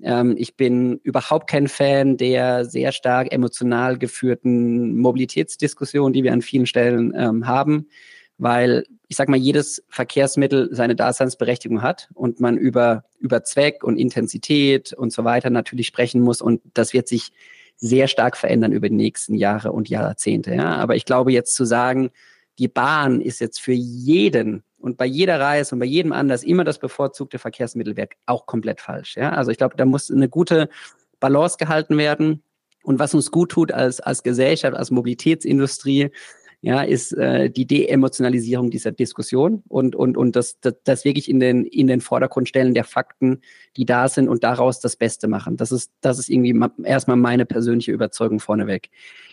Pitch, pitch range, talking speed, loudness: 125 Hz, 120-140 Hz, 170 wpm, -19 LUFS